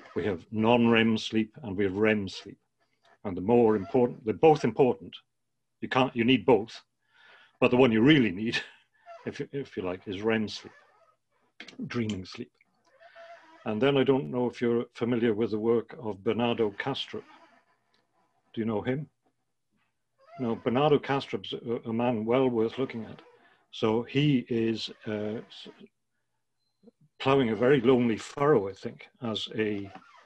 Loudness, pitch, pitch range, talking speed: -27 LUFS, 120 Hz, 110-135 Hz, 155 wpm